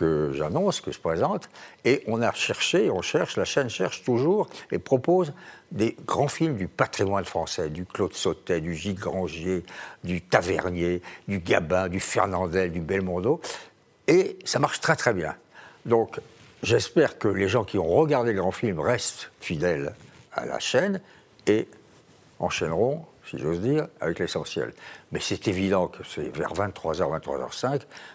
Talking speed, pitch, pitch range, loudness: 160 wpm, 95 Hz, 90-150 Hz, -26 LUFS